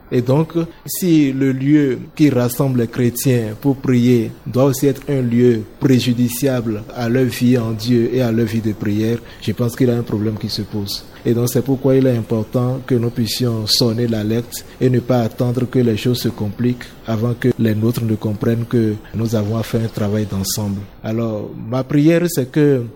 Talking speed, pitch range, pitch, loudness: 205 wpm, 110-130 Hz, 120 Hz, -17 LUFS